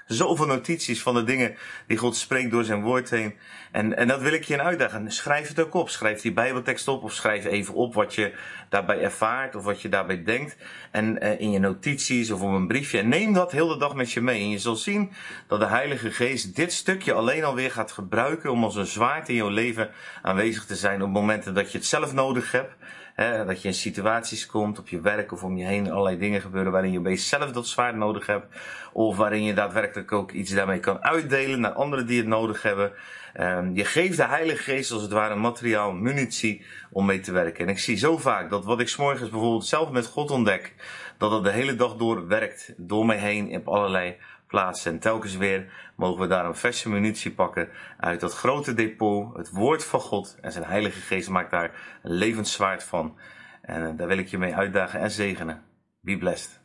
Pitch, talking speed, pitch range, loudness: 110 Hz, 225 wpm, 100-125 Hz, -25 LUFS